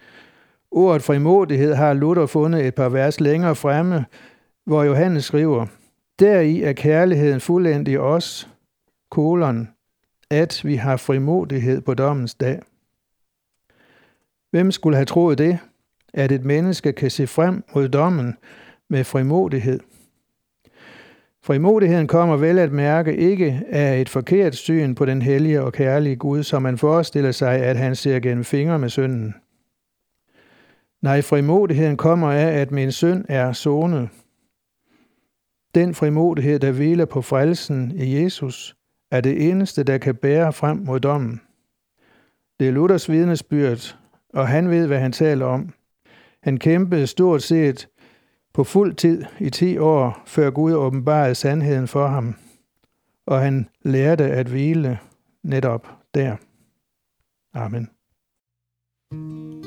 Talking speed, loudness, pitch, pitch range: 130 wpm, -19 LUFS, 145 Hz, 135-165 Hz